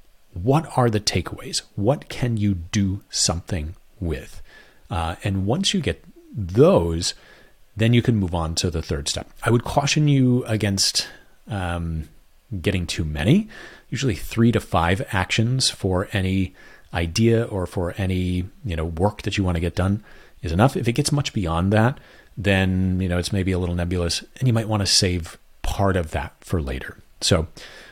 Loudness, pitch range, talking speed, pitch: -22 LUFS, 85-115 Hz, 175 wpm, 95 Hz